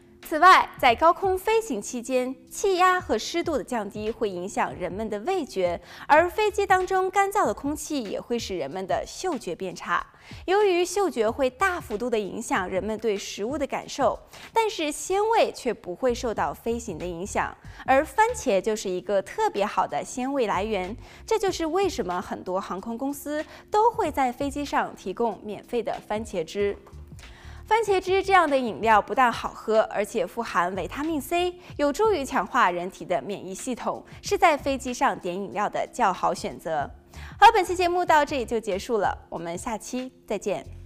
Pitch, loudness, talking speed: 255 Hz, -25 LUFS, 265 characters per minute